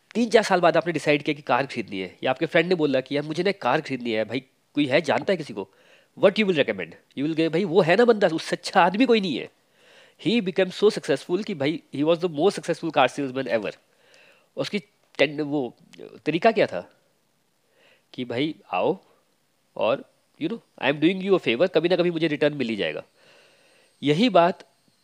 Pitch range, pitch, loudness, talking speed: 145-205 Hz, 170 Hz, -23 LUFS, 205 wpm